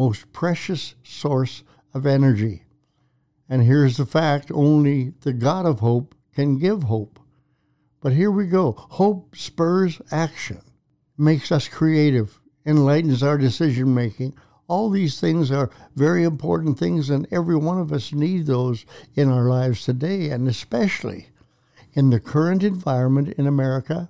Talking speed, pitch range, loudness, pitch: 140 wpm, 130-160 Hz, -21 LUFS, 145 Hz